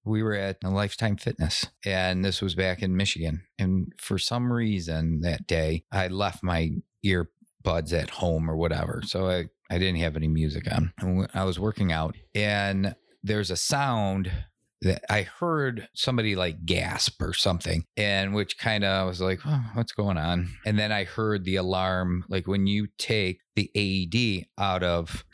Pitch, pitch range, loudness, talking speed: 95 Hz, 90-105 Hz, -27 LUFS, 180 wpm